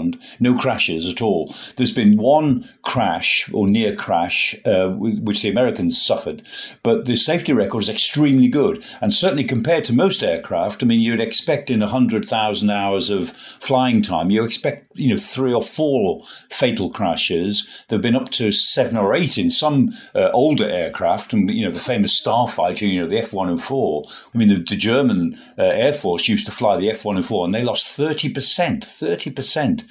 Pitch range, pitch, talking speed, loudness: 105-155 Hz, 125 Hz, 185 wpm, -18 LUFS